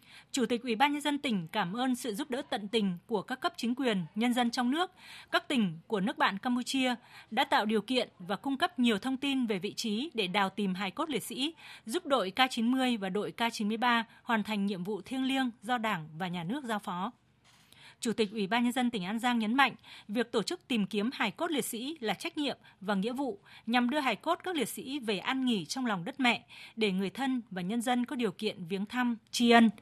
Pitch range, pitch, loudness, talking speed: 210-260 Hz, 235 Hz, -32 LUFS, 245 wpm